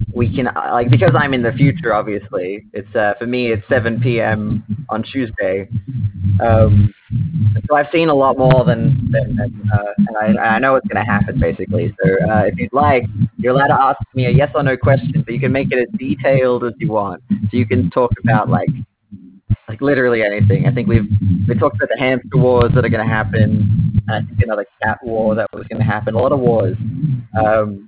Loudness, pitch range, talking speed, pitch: -16 LUFS, 105-130 Hz, 215 wpm, 115 Hz